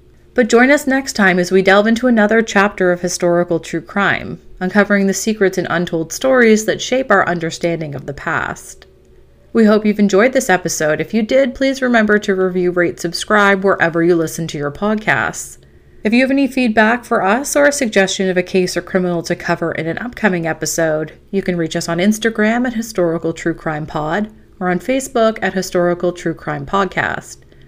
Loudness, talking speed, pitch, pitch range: -15 LUFS, 195 wpm, 190 Hz, 170-220 Hz